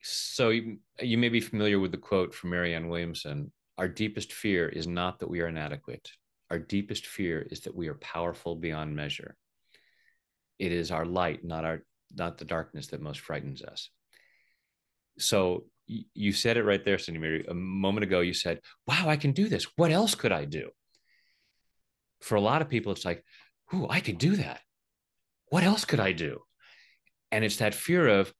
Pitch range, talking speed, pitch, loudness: 85-115 Hz, 185 wpm, 95 Hz, -30 LUFS